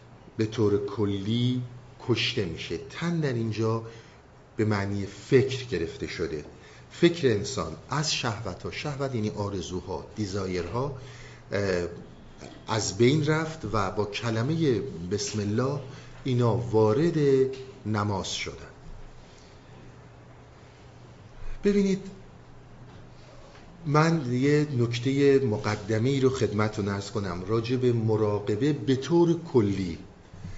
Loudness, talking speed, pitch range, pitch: -27 LUFS, 95 wpm, 105-135 Hz, 115 Hz